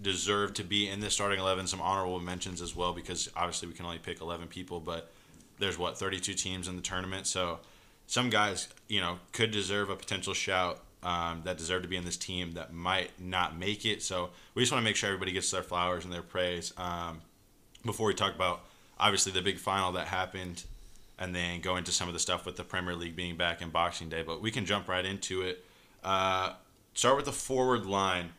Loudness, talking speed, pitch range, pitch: -32 LUFS, 225 wpm, 90-100 Hz, 90 Hz